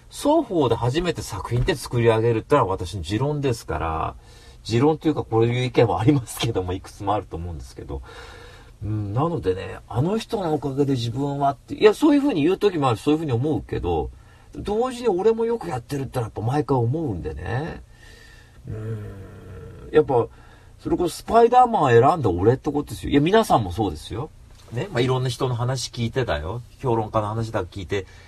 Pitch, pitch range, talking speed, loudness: 120 Hz, 105-150 Hz, 420 characters per minute, -22 LUFS